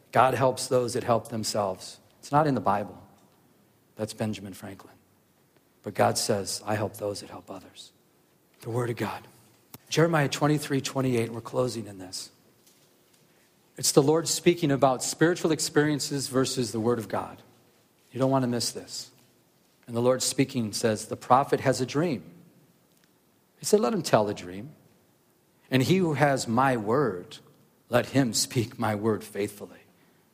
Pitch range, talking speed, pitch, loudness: 105-135 Hz, 160 wpm, 120 Hz, -26 LUFS